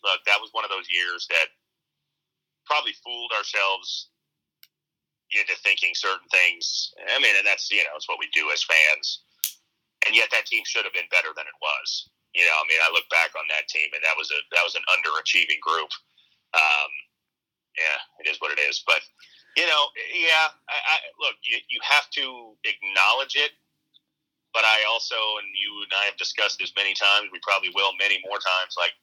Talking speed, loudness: 200 wpm, -22 LUFS